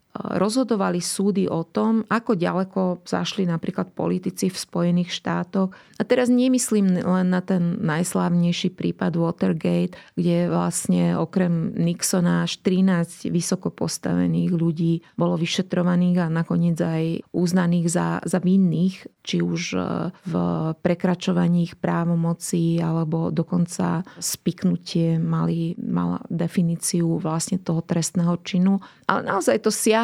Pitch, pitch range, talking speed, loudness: 175 Hz, 165-190 Hz, 120 wpm, -23 LUFS